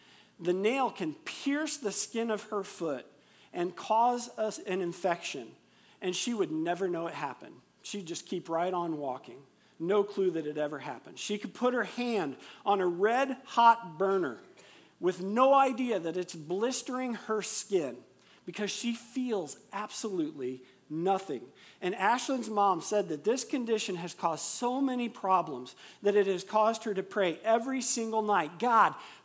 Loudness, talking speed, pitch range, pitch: -31 LUFS, 160 wpm, 180-240 Hz, 210 Hz